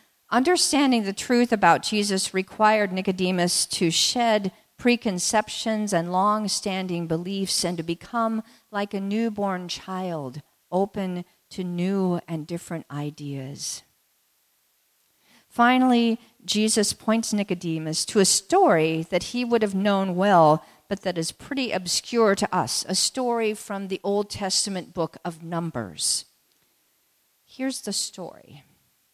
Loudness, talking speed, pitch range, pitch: -24 LUFS, 120 wpm, 175-220 Hz, 195 Hz